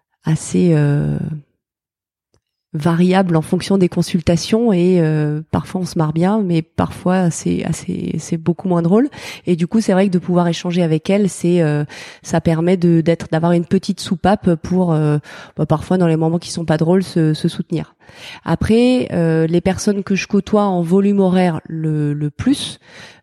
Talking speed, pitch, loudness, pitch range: 180 wpm, 175 Hz, -16 LUFS, 160-190 Hz